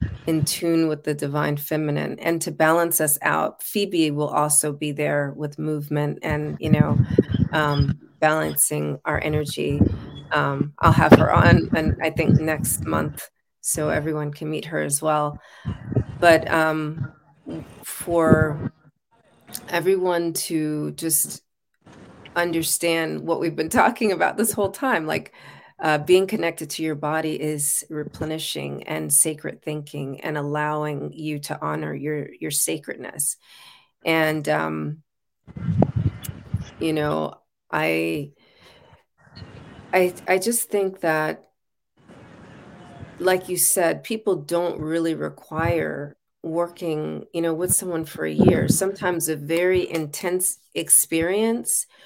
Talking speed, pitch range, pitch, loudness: 125 wpm, 145-170 Hz, 155 Hz, -22 LUFS